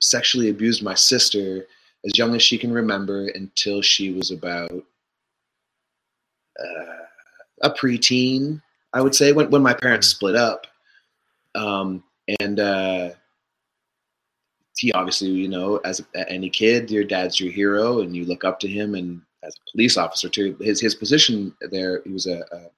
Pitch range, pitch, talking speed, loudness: 95-115 Hz, 100 Hz, 160 wpm, -19 LUFS